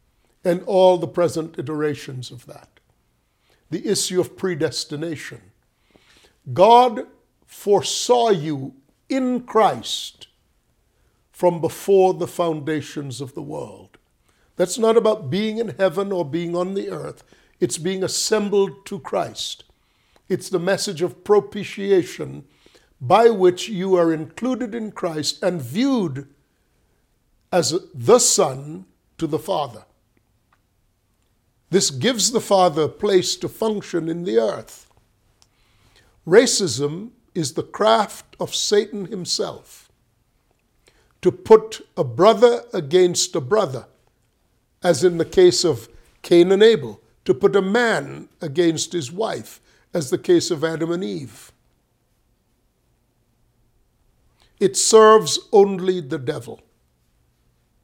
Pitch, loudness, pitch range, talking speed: 175 Hz, -19 LUFS, 140-200 Hz, 115 wpm